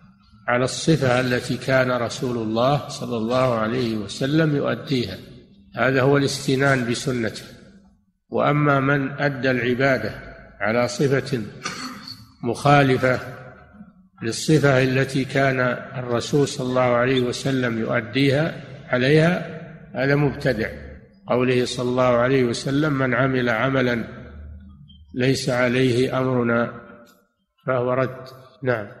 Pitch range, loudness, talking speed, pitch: 120-135 Hz, -21 LUFS, 100 wpm, 130 Hz